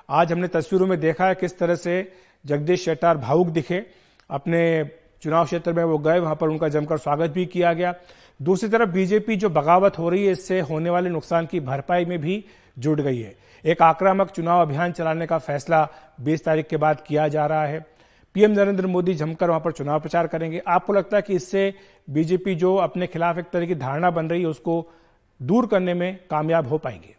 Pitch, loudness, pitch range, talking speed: 170 Hz, -22 LUFS, 155-180 Hz, 205 wpm